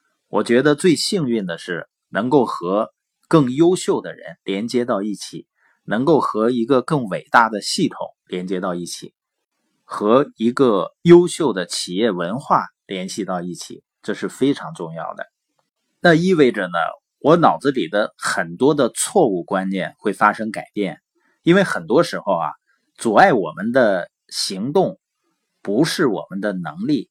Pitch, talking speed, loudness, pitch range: 115 Hz, 225 characters per minute, -19 LUFS, 95-160 Hz